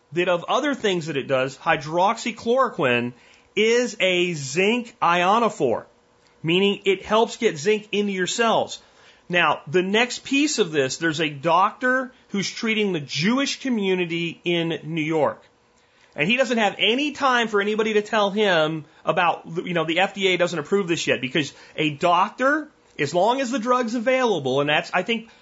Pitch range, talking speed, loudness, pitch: 165-230 Hz, 165 wpm, -22 LUFS, 195 Hz